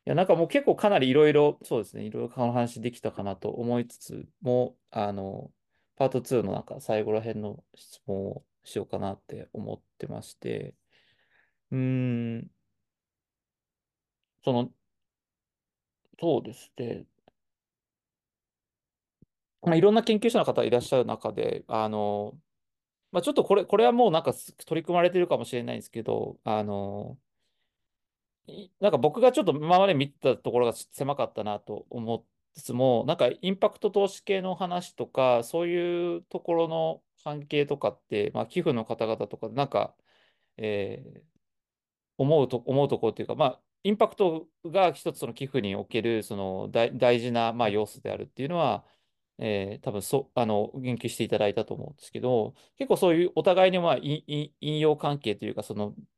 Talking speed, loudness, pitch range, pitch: 320 characters per minute, -27 LUFS, 110-170 Hz, 130 Hz